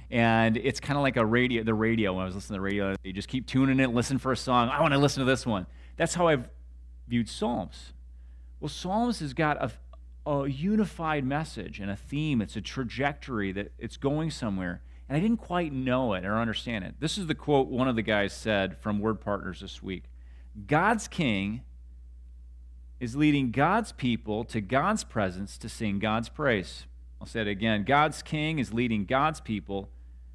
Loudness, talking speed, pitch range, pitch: -28 LUFS, 200 wpm, 95-140 Hz, 115 Hz